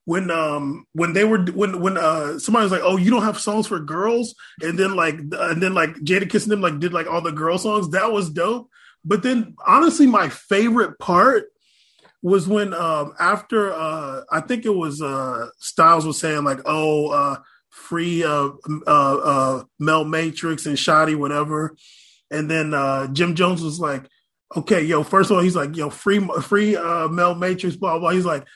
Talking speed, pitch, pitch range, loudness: 195 wpm, 170 Hz, 155-205 Hz, -20 LUFS